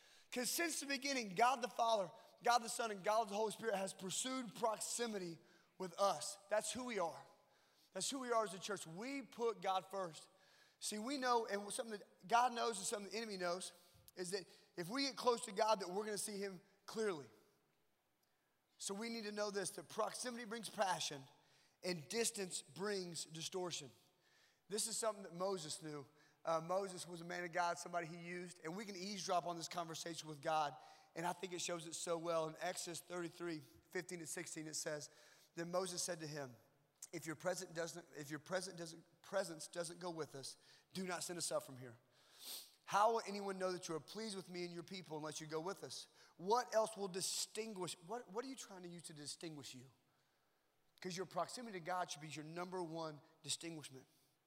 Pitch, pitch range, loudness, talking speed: 180 Hz, 165-210 Hz, -44 LUFS, 200 wpm